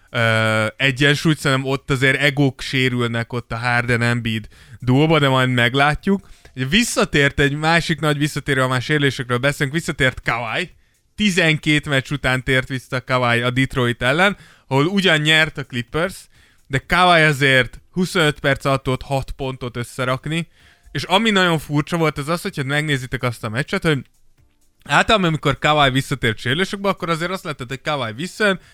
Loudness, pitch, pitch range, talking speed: -18 LUFS, 140 Hz, 130-160 Hz, 155 wpm